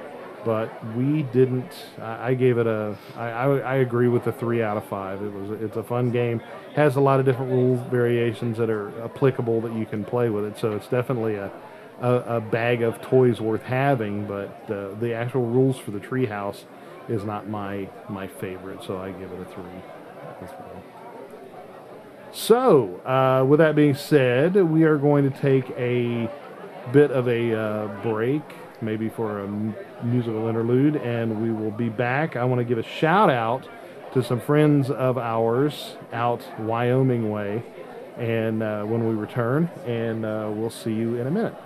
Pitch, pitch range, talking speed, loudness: 120 Hz, 110-130 Hz, 180 wpm, -23 LUFS